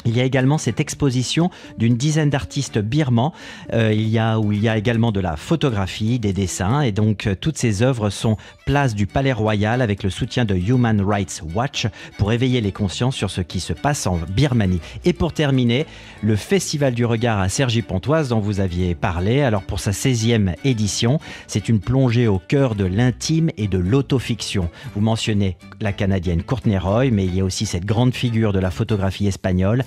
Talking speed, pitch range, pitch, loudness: 200 wpm, 100-130 Hz, 115 Hz, -20 LUFS